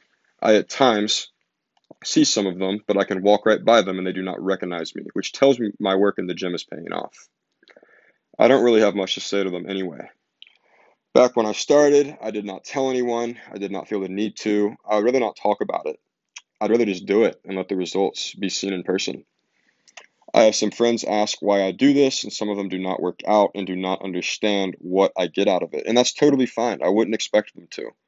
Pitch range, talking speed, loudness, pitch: 95-120 Hz, 240 wpm, -21 LUFS, 105 Hz